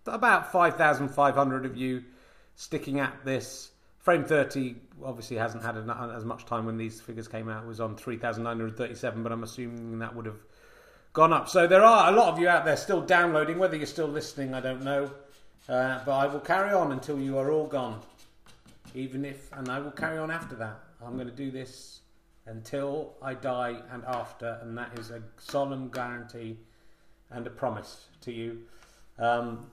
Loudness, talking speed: -28 LUFS, 190 wpm